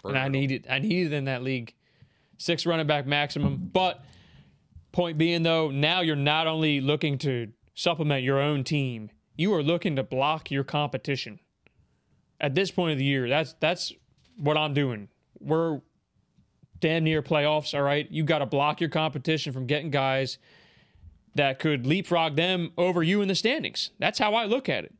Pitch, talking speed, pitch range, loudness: 150 Hz, 180 wpm, 135-165 Hz, -26 LUFS